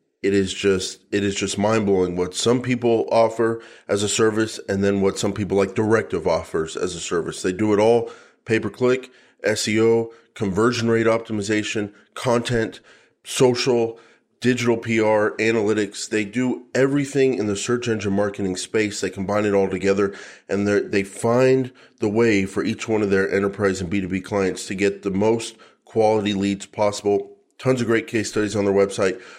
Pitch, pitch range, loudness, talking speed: 105 Hz, 100-115 Hz, -21 LUFS, 180 wpm